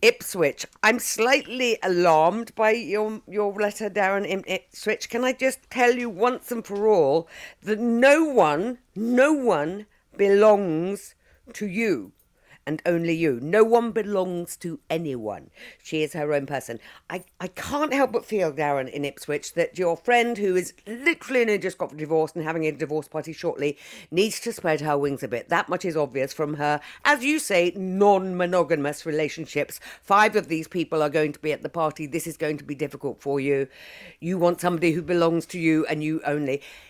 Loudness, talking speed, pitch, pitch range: -24 LUFS, 180 wpm, 175 Hz, 155-215 Hz